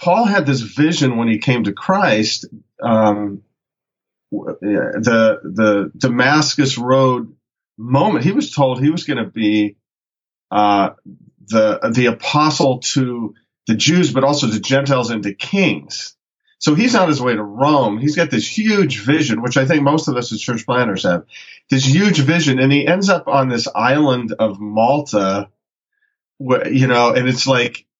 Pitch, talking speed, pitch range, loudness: 130 Hz, 165 wpm, 110-150 Hz, -16 LUFS